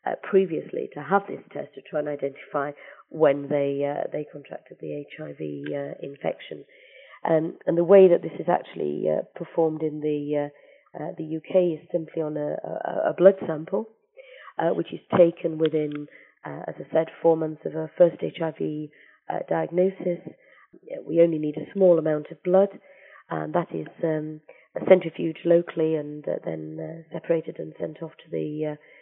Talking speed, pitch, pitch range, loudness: 175 wpm, 160 Hz, 150-175 Hz, -25 LUFS